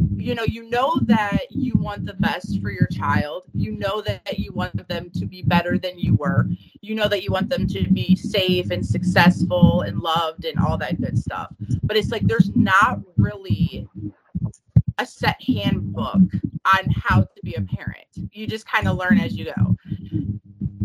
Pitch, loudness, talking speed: 165 Hz, -21 LUFS, 185 wpm